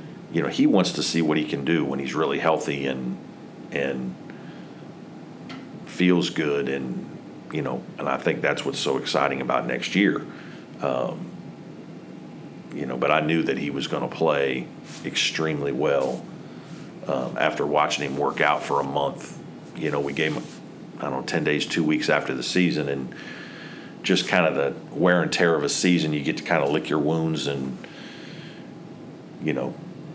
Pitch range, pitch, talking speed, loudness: 70-80 Hz, 70 Hz, 180 wpm, -24 LUFS